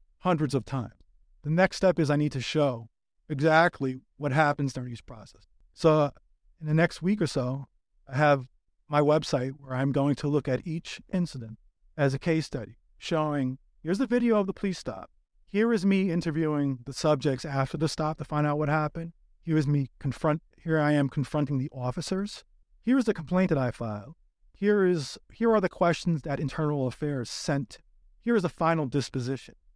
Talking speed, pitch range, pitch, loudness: 190 wpm, 130-165 Hz, 150 Hz, -28 LUFS